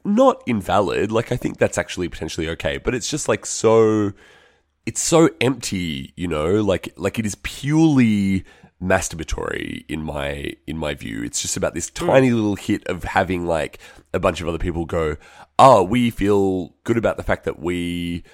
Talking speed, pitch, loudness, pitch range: 180 wpm, 100 Hz, -20 LUFS, 85-120 Hz